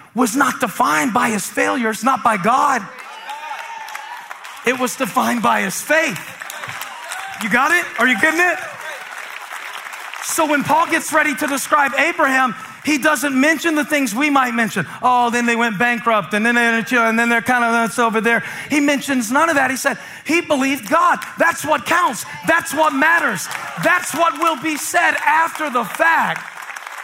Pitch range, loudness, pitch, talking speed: 240-320 Hz, -16 LUFS, 280 Hz, 175 wpm